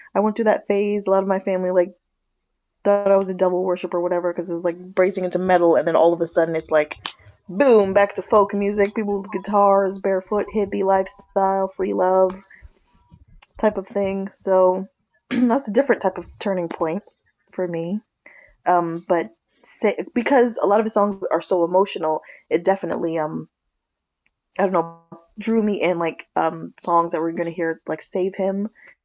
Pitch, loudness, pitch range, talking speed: 190 Hz, -20 LUFS, 170-200 Hz, 190 wpm